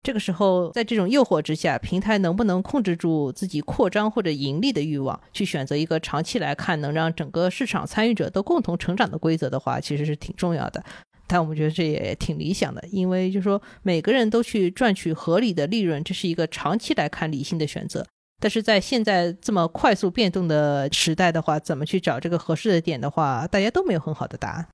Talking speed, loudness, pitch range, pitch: 350 characters per minute, -23 LUFS, 155-200 Hz, 175 Hz